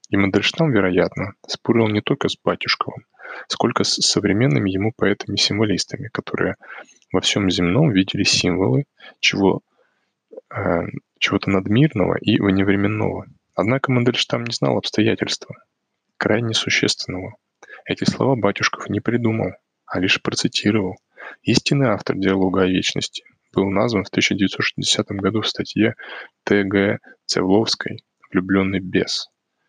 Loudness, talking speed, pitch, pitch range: -19 LUFS, 115 wpm, 100 Hz, 95-120 Hz